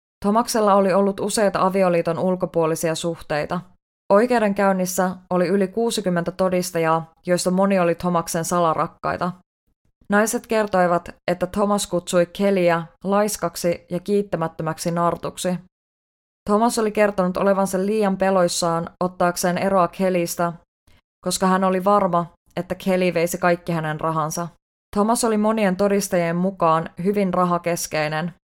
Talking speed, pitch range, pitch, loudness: 110 wpm, 170-195 Hz, 180 Hz, -21 LUFS